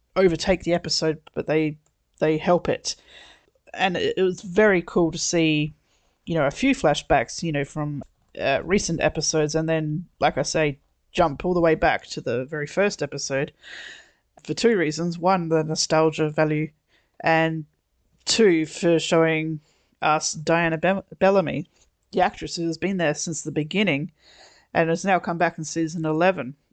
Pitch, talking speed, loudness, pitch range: 160 Hz, 160 wpm, -23 LUFS, 155-175 Hz